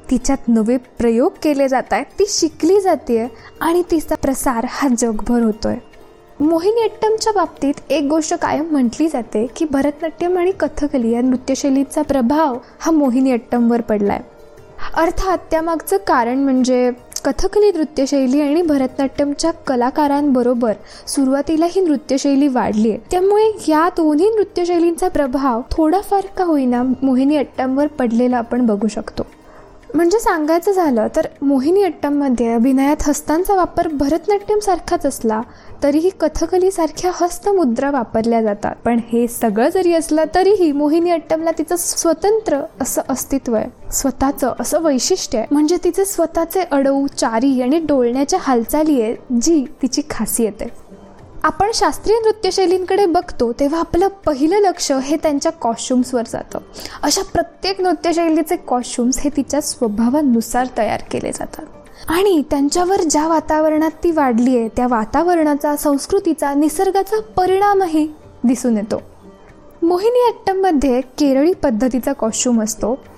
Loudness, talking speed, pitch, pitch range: -17 LUFS, 125 wpm, 295 Hz, 255-345 Hz